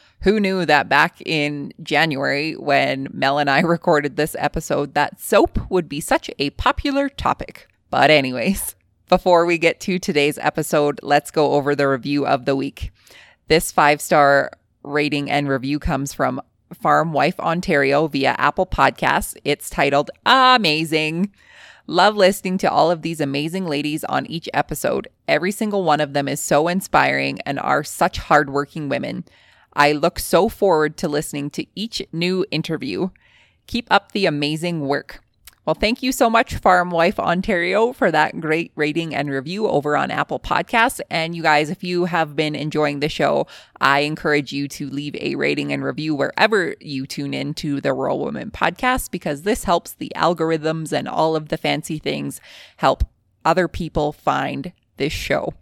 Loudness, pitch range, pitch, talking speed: -19 LUFS, 145-175 Hz, 155 Hz, 170 wpm